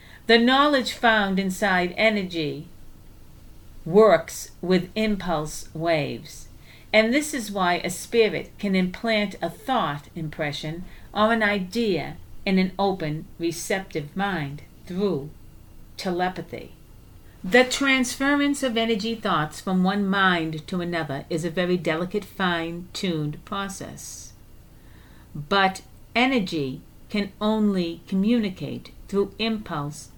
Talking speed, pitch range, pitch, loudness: 105 wpm, 160-215 Hz, 185 Hz, -24 LUFS